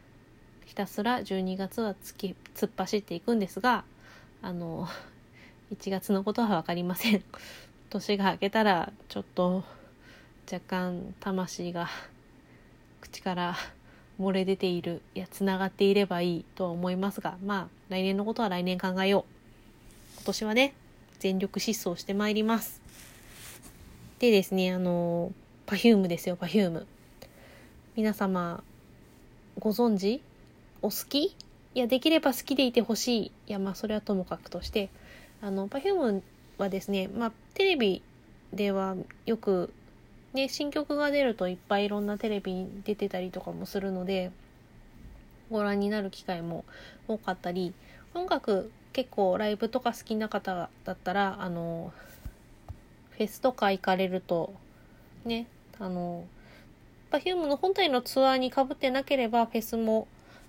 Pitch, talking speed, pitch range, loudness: 200 Hz, 280 characters per minute, 185-230 Hz, -30 LUFS